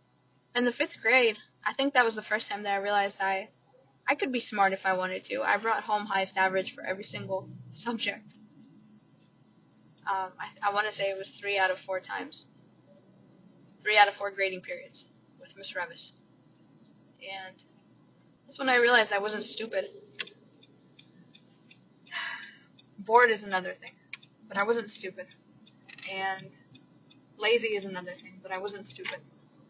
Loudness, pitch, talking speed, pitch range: -29 LUFS, 200 Hz, 160 wpm, 190-220 Hz